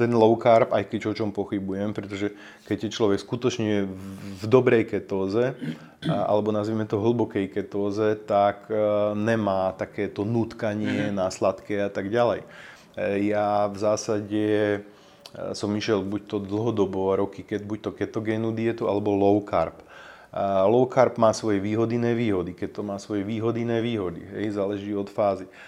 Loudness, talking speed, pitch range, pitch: -25 LUFS, 145 wpm, 100-110 Hz, 105 Hz